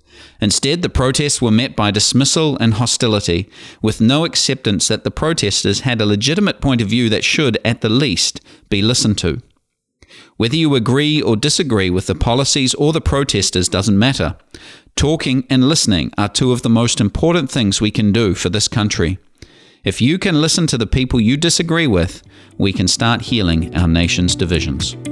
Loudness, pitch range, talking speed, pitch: -15 LUFS, 100-135 Hz, 180 wpm, 115 Hz